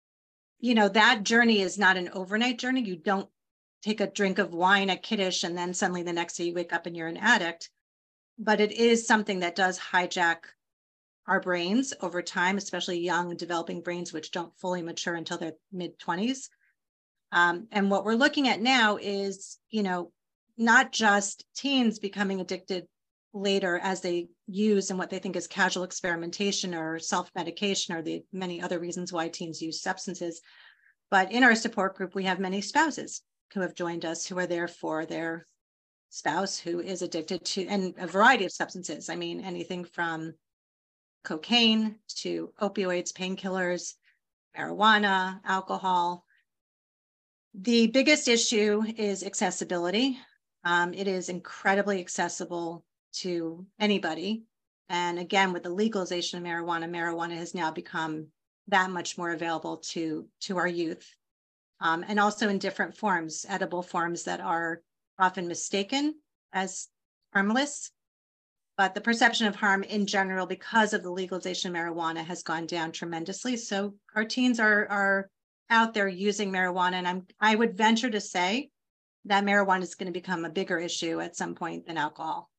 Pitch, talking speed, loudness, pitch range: 185 Hz, 160 wpm, -28 LUFS, 175-205 Hz